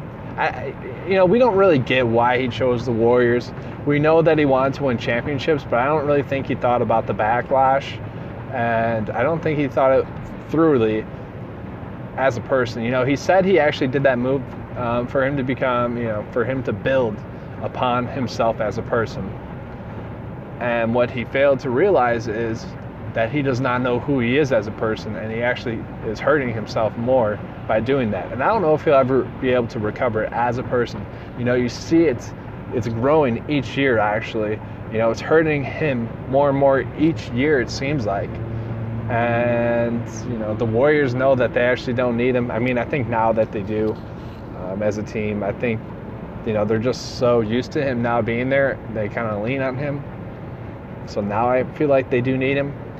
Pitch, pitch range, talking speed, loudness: 125 Hz, 115-135 Hz, 210 wpm, -20 LUFS